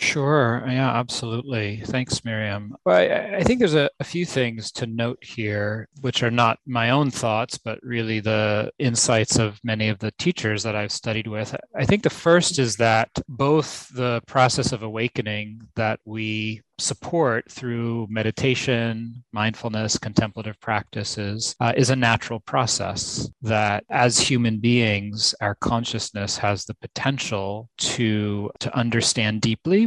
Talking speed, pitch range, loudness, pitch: 145 wpm, 110-130 Hz, -23 LUFS, 115 Hz